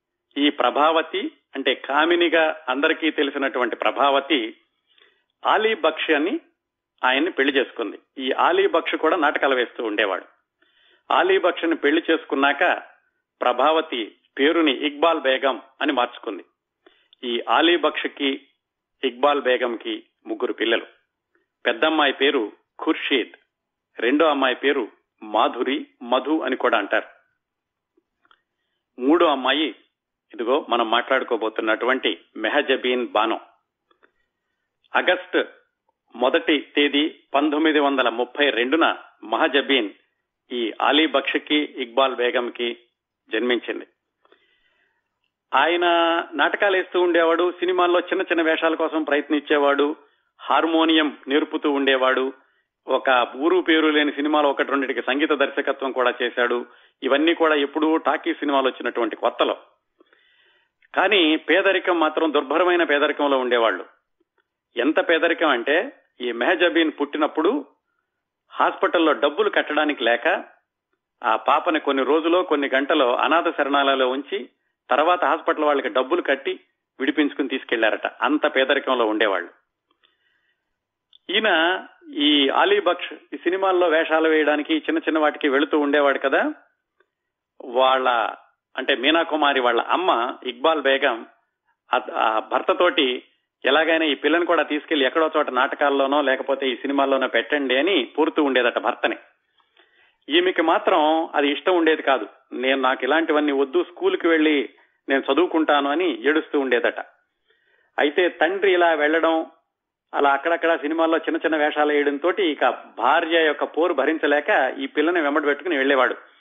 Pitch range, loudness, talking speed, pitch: 140-175 Hz, -21 LUFS, 110 wpm, 155 Hz